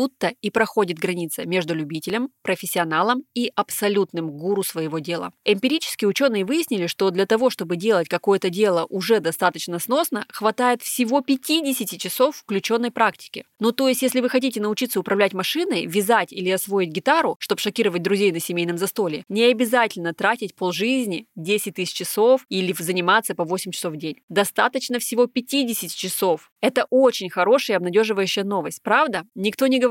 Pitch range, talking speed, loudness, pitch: 185-245 Hz, 155 wpm, -21 LUFS, 205 Hz